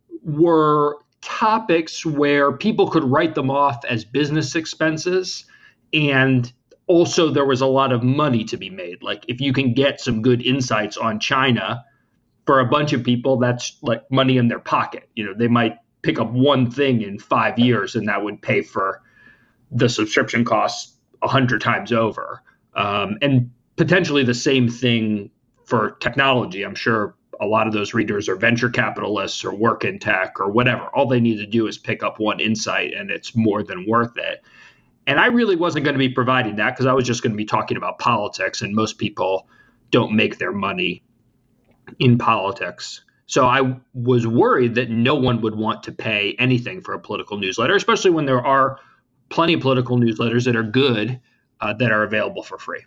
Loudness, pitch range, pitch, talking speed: -19 LUFS, 115-140 Hz, 125 Hz, 190 wpm